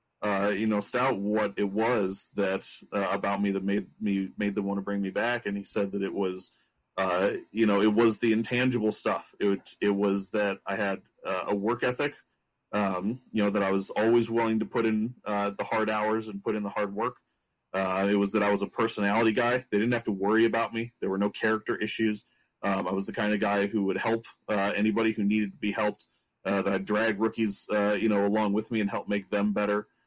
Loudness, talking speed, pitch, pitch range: -28 LUFS, 240 wpm, 105 Hz, 100-110 Hz